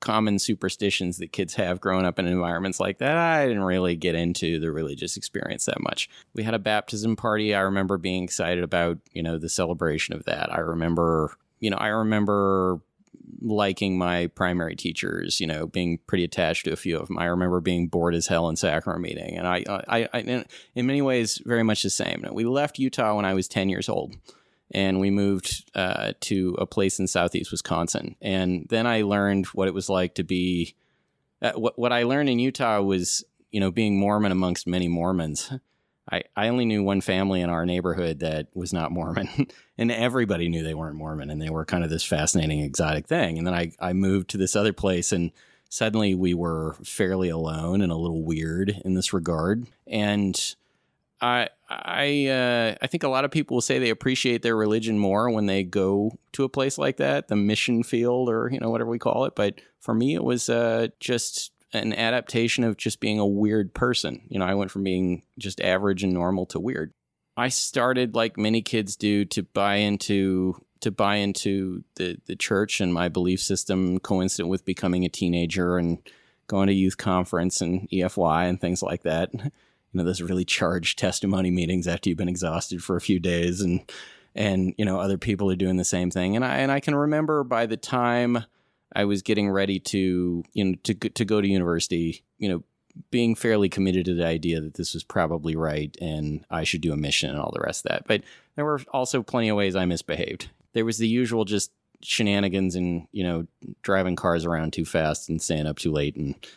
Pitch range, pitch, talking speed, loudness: 90-110 Hz, 95 Hz, 210 wpm, -25 LUFS